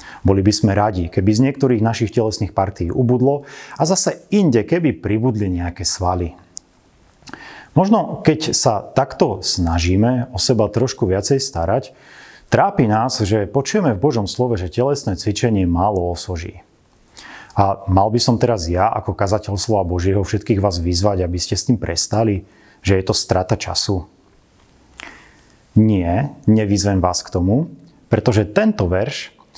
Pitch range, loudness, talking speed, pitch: 95-125 Hz, -18 LUFS, 145 wpm, 105 Hz